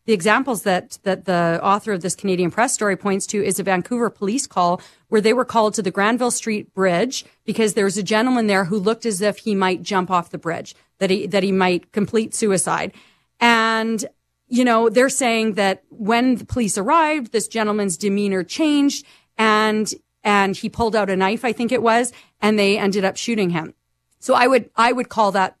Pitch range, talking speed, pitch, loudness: 195-230 Hz, 205 wpm, 215 Hz, -19 LUFS